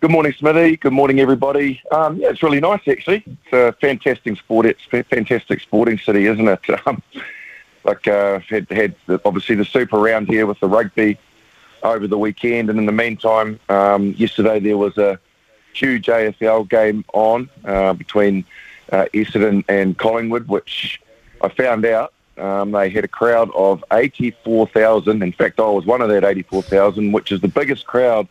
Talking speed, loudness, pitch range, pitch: 180 wpm, -16 LUFS, 100-115 Hz, 110 Hz